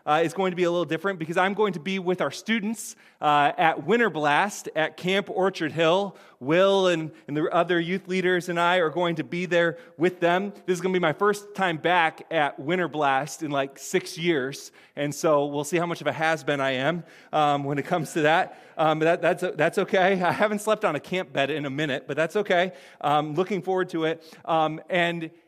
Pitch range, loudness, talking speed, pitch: 155-185 Hz, -25 LUFS, 230 wpm, 170 Hz